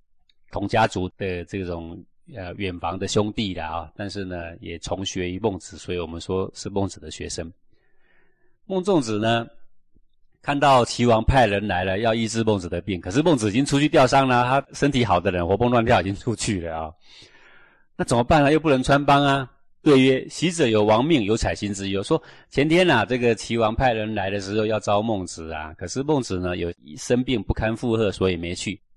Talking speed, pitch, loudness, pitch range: 295 characters per minute, 105 Hz, -22 LUFS, 90-125 Hz